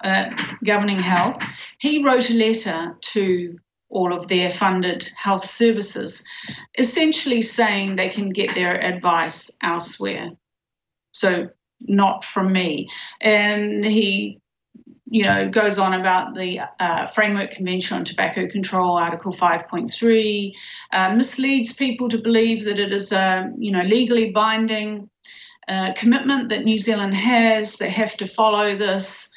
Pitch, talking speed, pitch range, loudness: 205 Hz, 135 wpm, 185-230 Hz, -19 LUFS